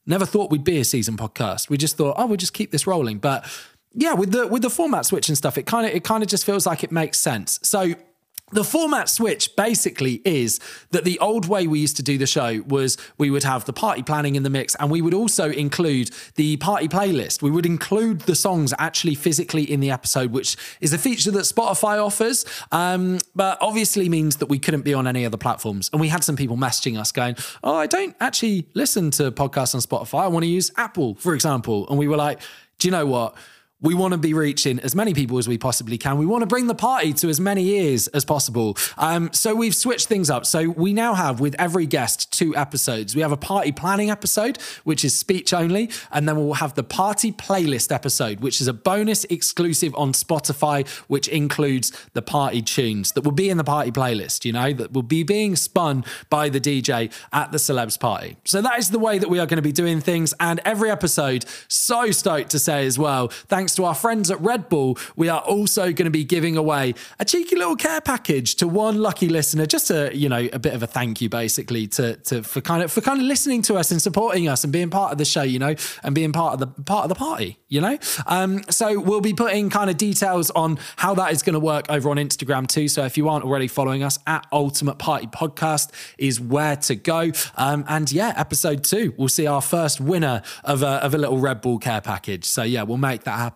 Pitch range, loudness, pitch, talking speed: 135-190 Hz, -21 LUFS, 155 Hz, 240 wpm